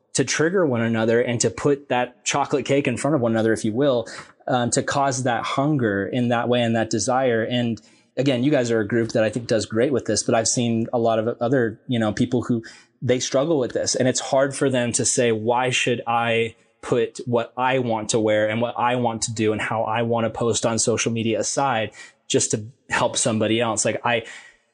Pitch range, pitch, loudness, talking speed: 115-130 Hz, 120 Hz, -21 LUFS, 235 wpm